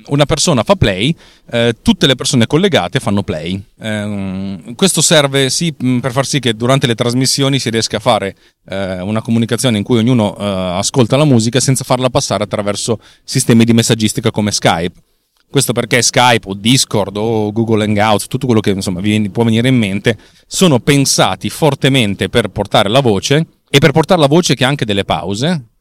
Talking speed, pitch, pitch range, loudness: 185 wpm, 120 Hz, 105-135 Hz, -13 LUFS